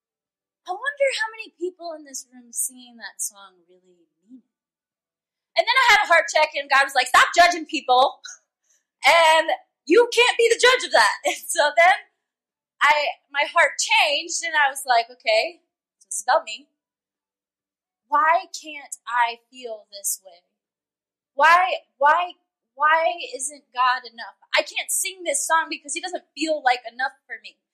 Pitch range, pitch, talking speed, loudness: 250-345 Hz, 300 Hz, 165 wpm, -20 LUFS